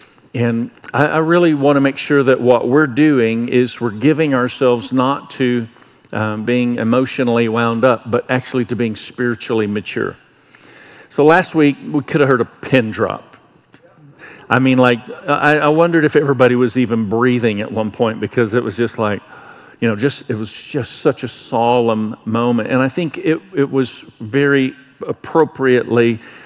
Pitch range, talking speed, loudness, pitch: 115-140 Hz, 170 wpm, -16 LUFS, 125 Hz